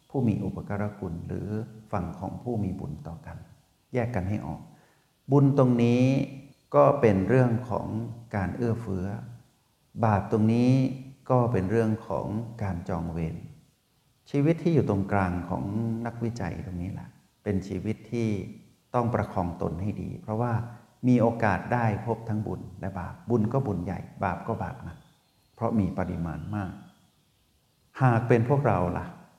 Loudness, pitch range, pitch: -28 LUFS, 95-120 Hz, 110 Hz